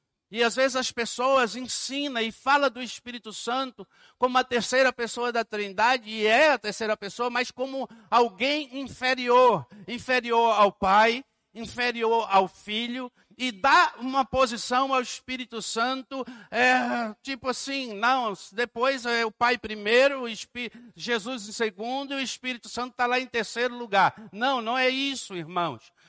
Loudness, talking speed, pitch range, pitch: -25 LUFS, 155 wpm, 220-255 Hz, 240 Hz